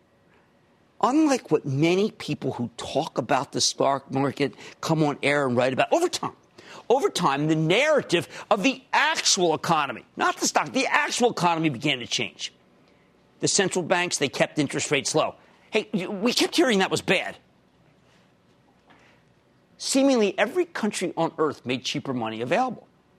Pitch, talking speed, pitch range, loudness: 160 Hz, 155 wpm, 135-220 Hz, -24 LUFS